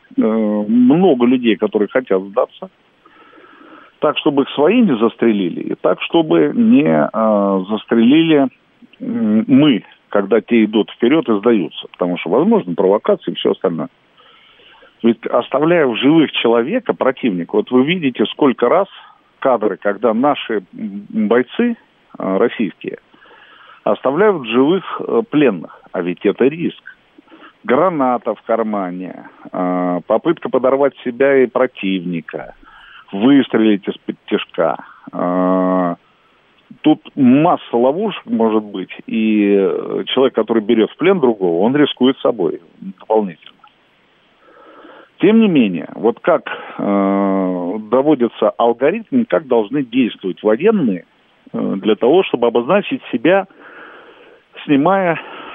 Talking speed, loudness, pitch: 105 wpm, -15 LUFS, 125 Hz